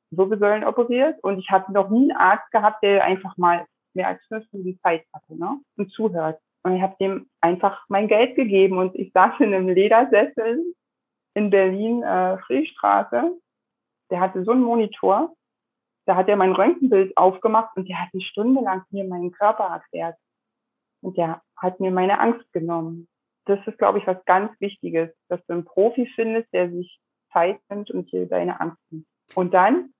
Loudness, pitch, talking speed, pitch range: -21 LUFS, 195 Hz, 185 wpm, 185-225 Hz